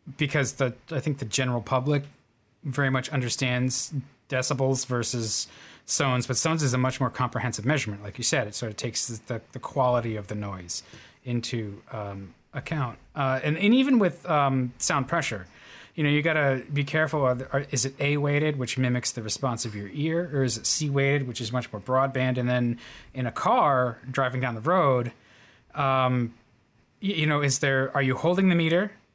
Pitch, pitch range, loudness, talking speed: 130 Hz, 120-145 Hz, -26 LUFS, 200 wpm